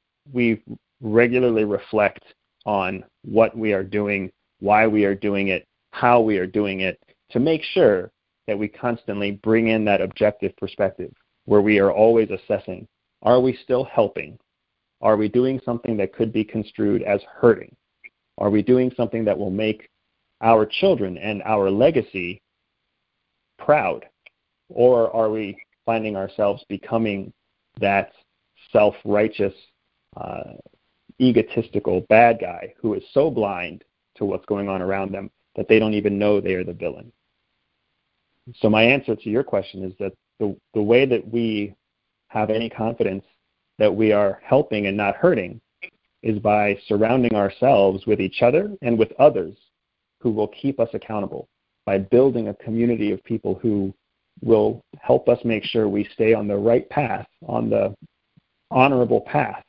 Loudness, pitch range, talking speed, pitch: -21 LUFS, 100-115 Hz, 155 wpm, 105 Hz